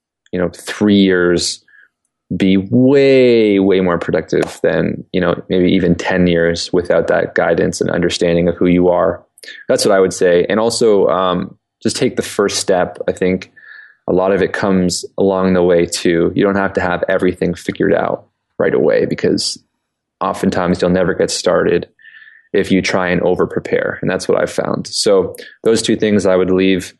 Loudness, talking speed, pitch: -14 LUFS, 185 wpm, 95 Hz